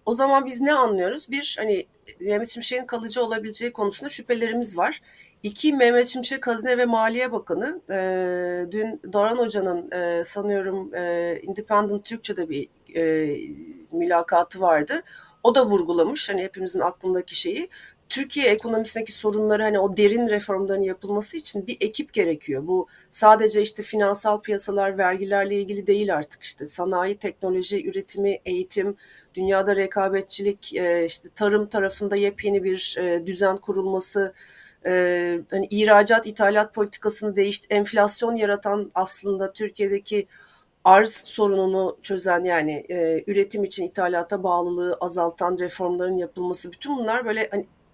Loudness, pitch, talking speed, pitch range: -22 LUFS, 200 Hz, 120 wpm, 185-215 Hz